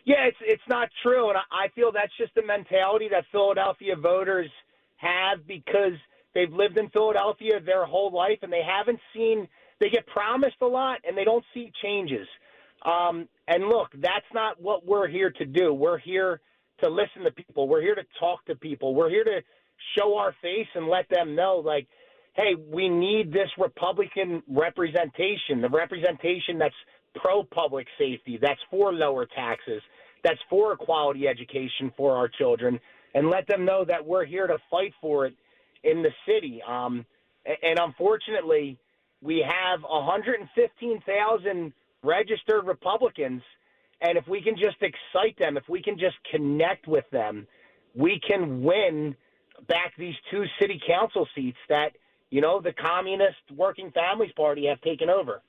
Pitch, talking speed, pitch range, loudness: 190 Hz, 165 wpm, 170-225 Hz, -26 LUFS